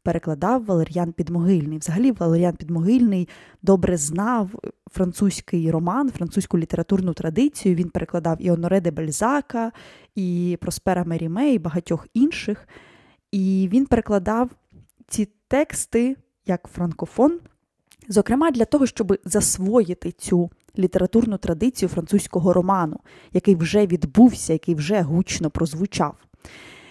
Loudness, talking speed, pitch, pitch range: -21 LUFS, 110 wpm, 185 Hz, 170-215 Hz